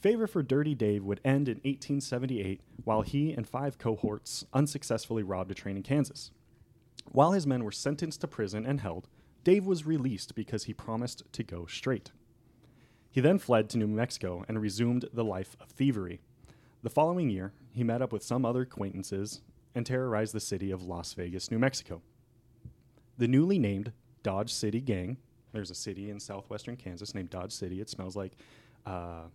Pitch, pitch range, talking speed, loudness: 115 Hz, 100-135 Hz, 180 wpm, -32 LUFS